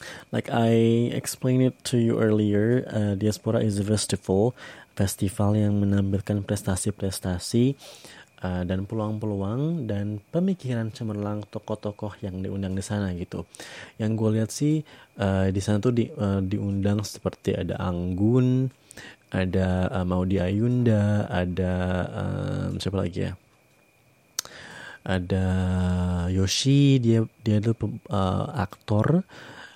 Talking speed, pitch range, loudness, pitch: 115 wpm, 95-115 Hz, -25 LUFS, 105 Hz